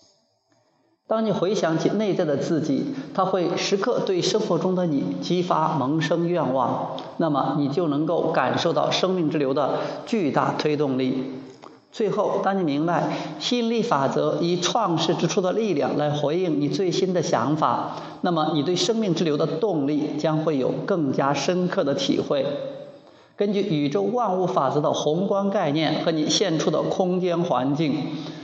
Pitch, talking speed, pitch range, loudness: 170 Hz, 245 characters per minute, 150-190 Hz, -23 LUFS